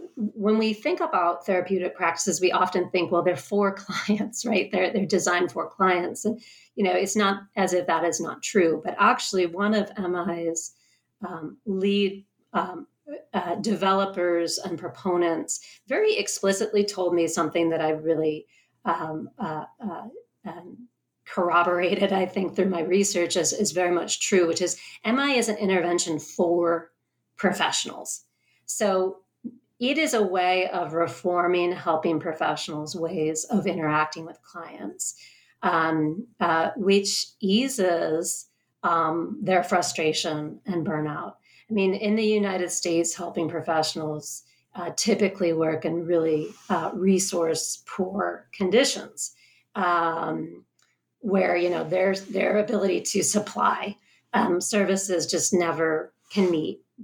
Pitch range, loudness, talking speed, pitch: 170-200 Hz, -25 LUFS, 135 wpm, 180 Hz